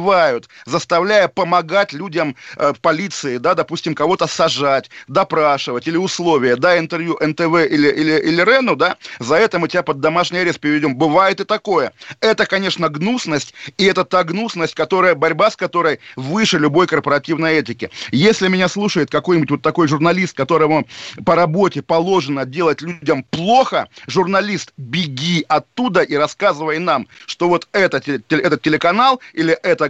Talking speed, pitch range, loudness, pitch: 145 wpm, 155-185 Hz, -16 LUFS, 170 Hz